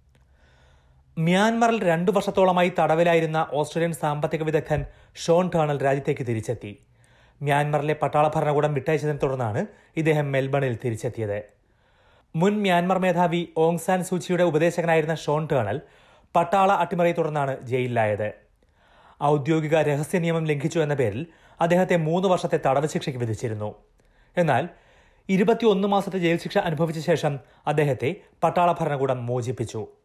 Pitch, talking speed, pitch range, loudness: 155 Hz, 110 wpm, 130-170 Hz, -23 LUFS